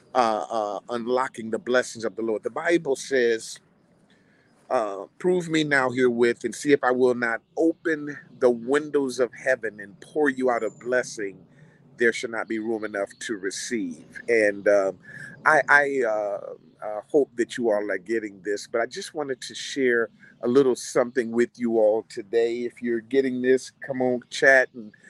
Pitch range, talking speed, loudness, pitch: 115-145 Hz, 180 wpm, -24 LUFS, 125 Hz